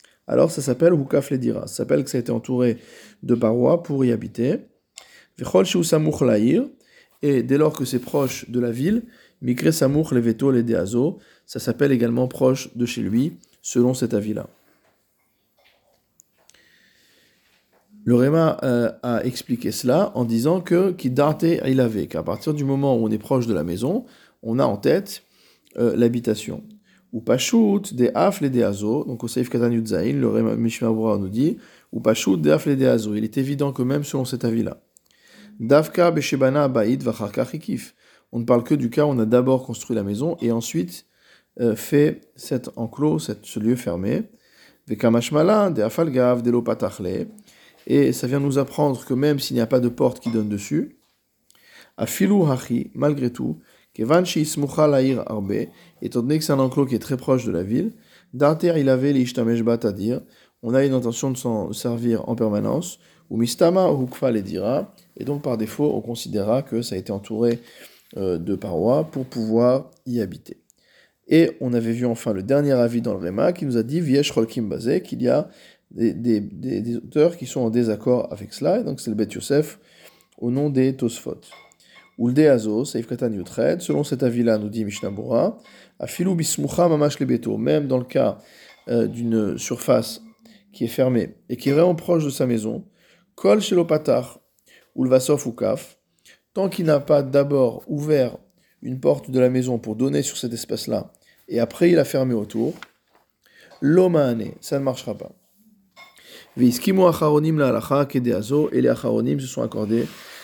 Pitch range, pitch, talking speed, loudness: 115-145 Hz, 130 Hz, 170 wpm, -21 LUFS